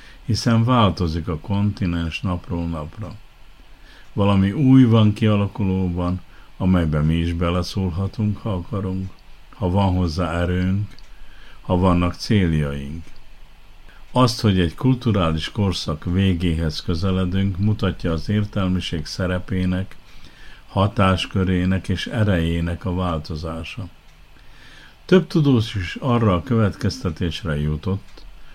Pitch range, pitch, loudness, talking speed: 85-105 Hz, 95 Hz, -21 LUFS, 95 wpm